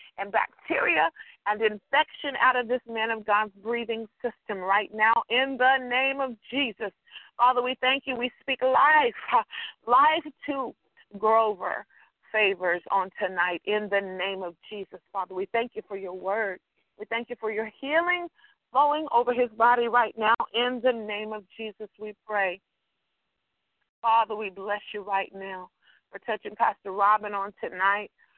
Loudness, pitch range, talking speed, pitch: -26 LUFS, 200-250 Hz, 160 wpm, 220 Hz